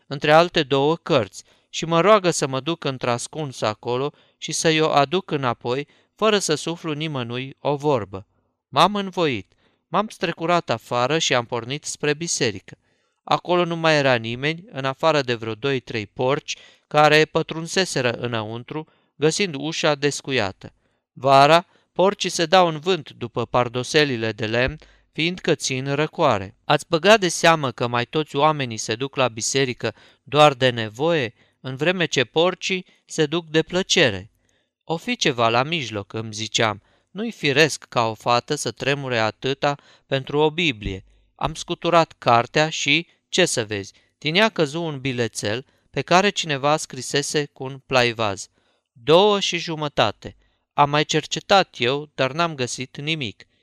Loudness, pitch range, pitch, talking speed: -21 LUFS, 120-165 Hz, 145 Hz, 150 wpm